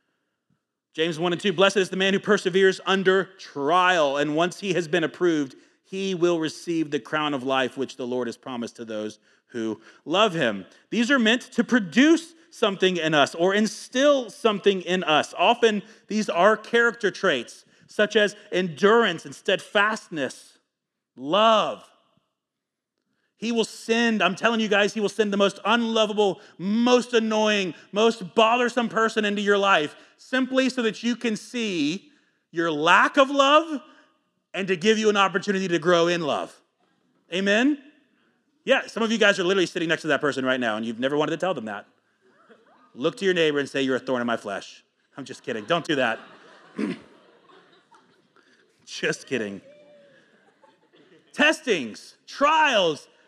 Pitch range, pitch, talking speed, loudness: 170-235 Hz, 200 Hz, 165 wpm, -23 LUFS